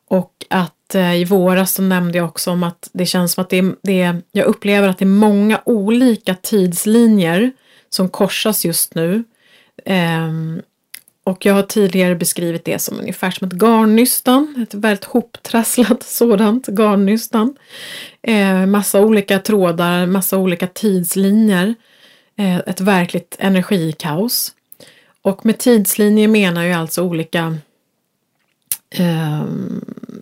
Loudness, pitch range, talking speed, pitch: -15 LUFS, 180-220 Hz, 130 wpm, 195 Hz